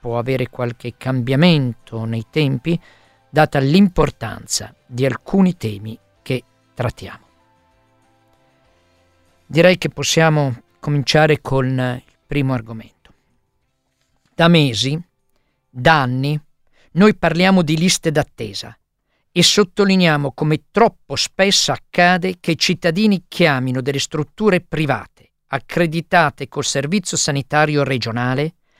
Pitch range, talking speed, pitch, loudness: 120-165 Hz, 100 wpm, 140 Hz, -17 LUFS